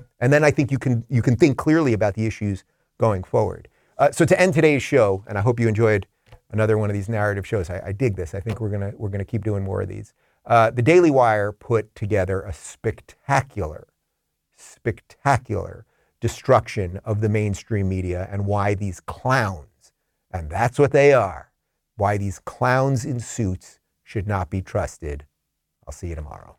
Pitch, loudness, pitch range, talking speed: 105 Hz, -21 LUFS, 95-120 Hz, 190 wpm